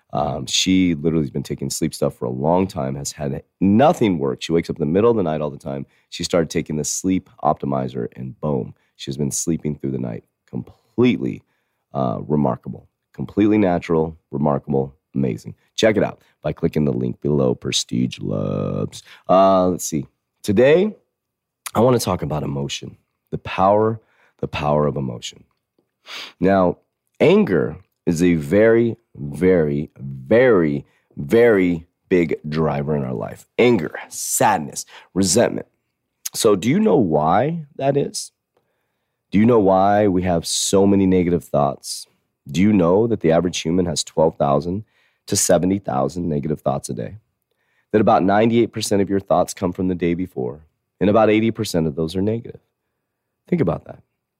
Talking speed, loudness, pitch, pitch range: 160 wpm, -19 LUFS, 85 Hz, 70-95 Hz